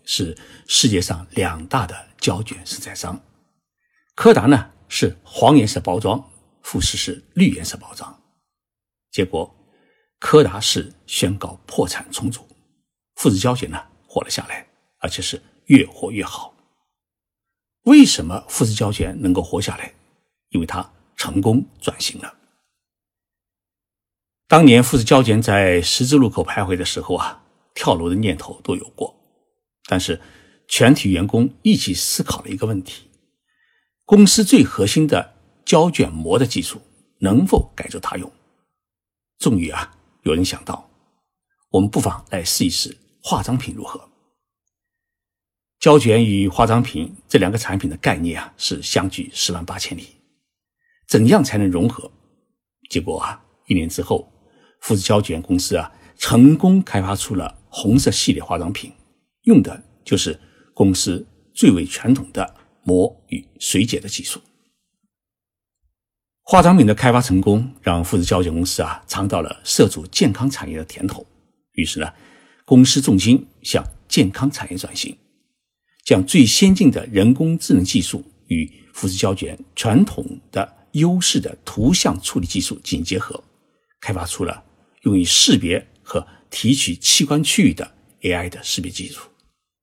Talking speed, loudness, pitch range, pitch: 215 characters per minute, -17 LUFS, 95-140 Hz, 105 Hz